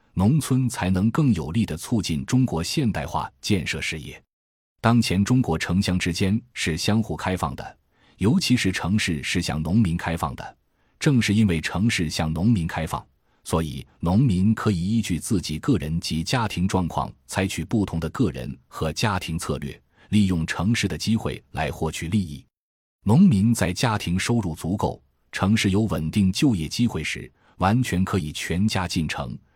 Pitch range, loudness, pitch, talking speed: 80-110 Hz, -23 LUFS, 95 Hz, 250 characters per minute